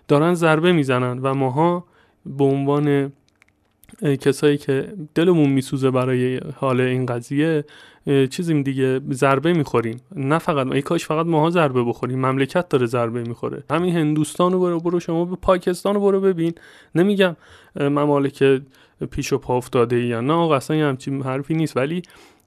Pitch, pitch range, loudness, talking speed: 145 Hz, 130-165 Hz, -20 LUFS, 150 wpm